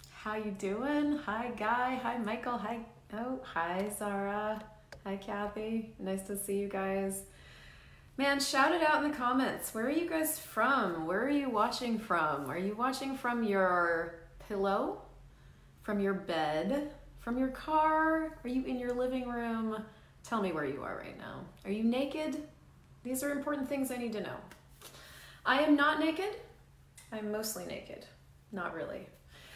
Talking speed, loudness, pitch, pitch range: 160 wpm, -34 LUFS, 230 Hz, 200-270 Hz